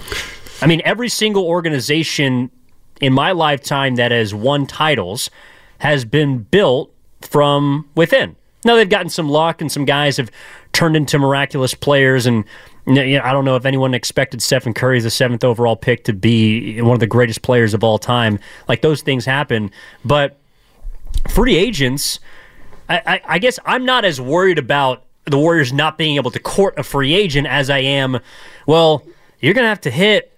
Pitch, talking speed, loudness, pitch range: 140 Hz, 180 wpm, -15 LUFS, 125-155 Hz